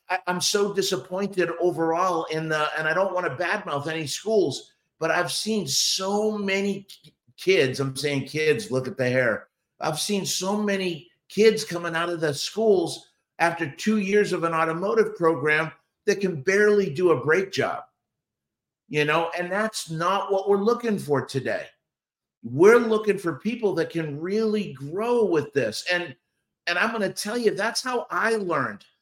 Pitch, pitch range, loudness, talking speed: 180 Hz, 160-205 Hz, -24 LUFS, 170 wpm